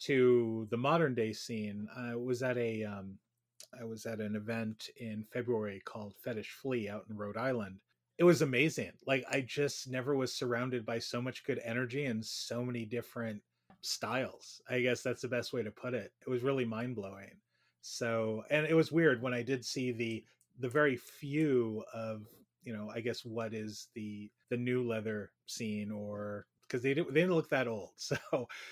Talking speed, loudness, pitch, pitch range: 190 wpm, -35 LUFS, 120 Hz, 110-130 Hz